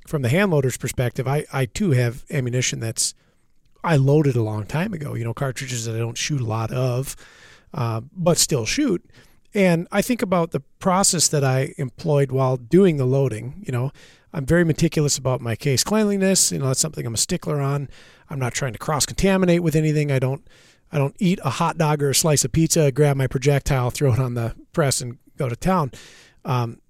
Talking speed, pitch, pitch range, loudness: 210 wpm, 140 Hz, 130-160 Hz, -21 LUFS